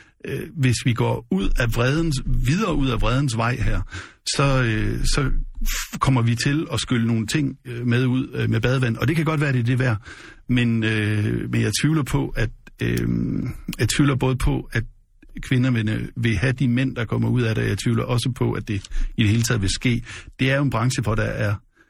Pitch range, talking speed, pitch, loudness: 110-130 Hz, 205 wpm, 120 Hz, -22 LUFS